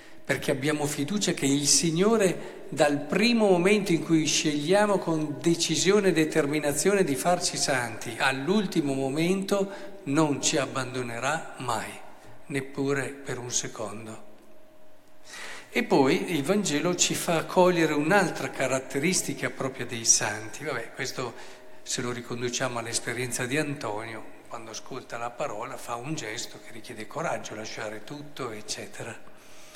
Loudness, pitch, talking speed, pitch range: -26 LUFS, 150 Hz, 125 wpm, 135-180 Hz